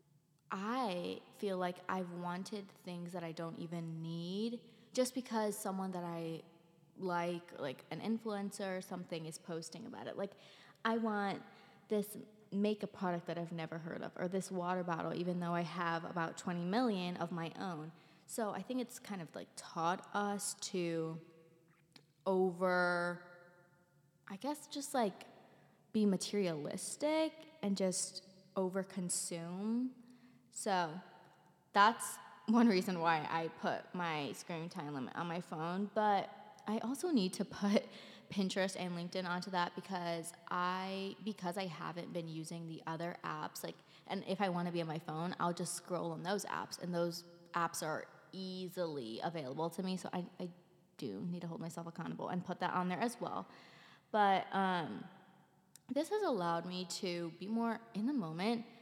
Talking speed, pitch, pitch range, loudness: 160 wpm, 180 Hz, 170-205 Hz, -39 LUFS